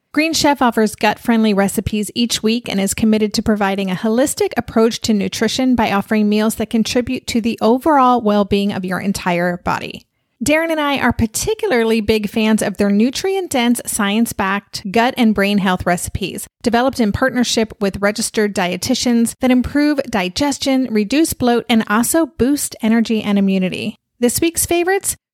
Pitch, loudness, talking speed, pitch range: 225 Hz, -16 LUFS, 155 wpm, 210-255 Hz